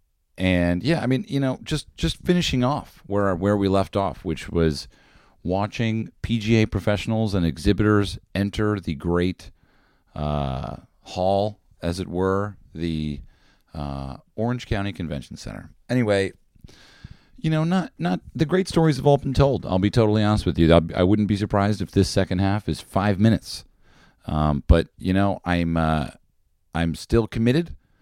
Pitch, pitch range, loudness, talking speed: 100 Hz, 85-110 Hz, -23 LUFS, 160 wpm